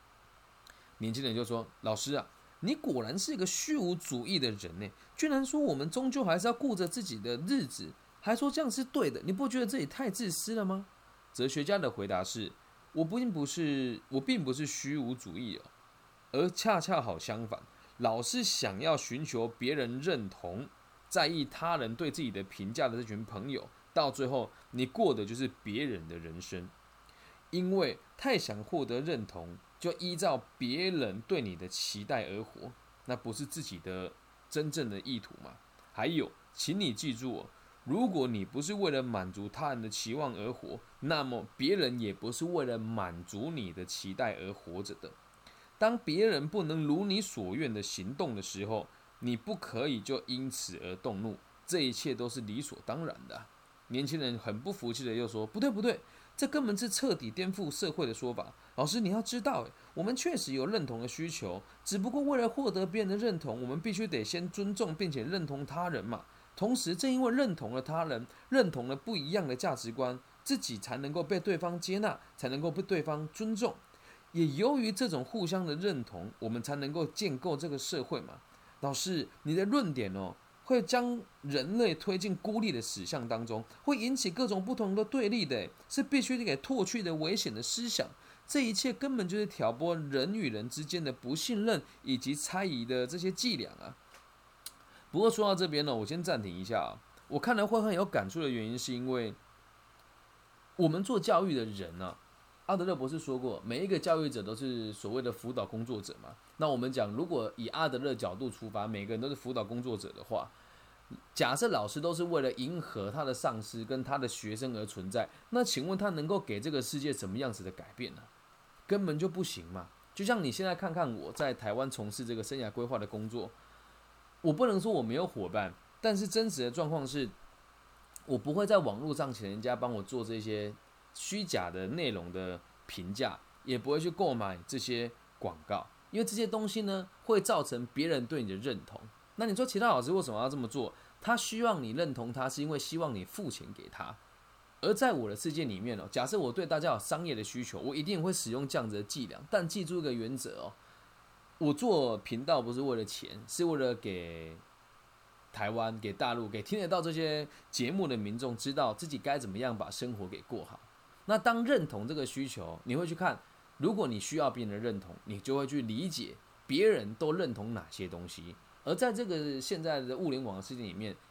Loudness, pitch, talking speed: -35 LUFS, 140 Hz, 290 characters per minute